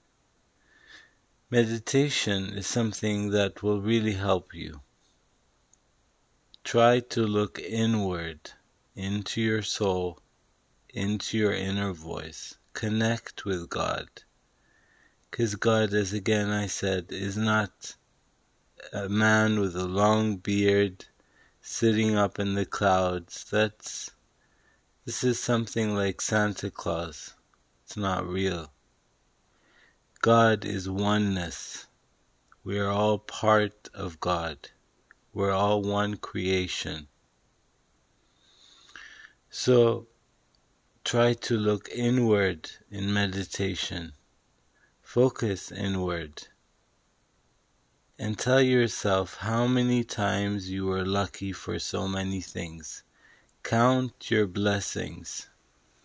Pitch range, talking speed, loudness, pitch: 95-110 Hz, 95 wpm, -27 LUFS, 100 Hz